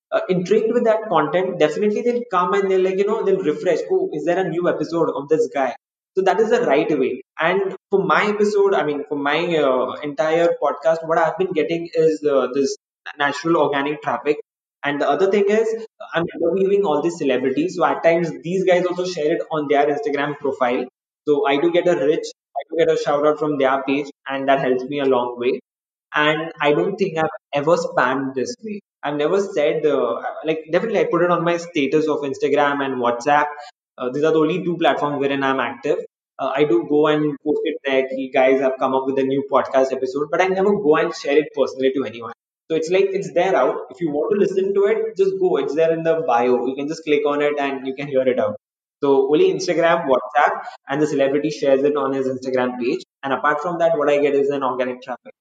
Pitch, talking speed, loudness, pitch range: 155 Hz, 235 wpm, -19 LUFS, 140-185 Hz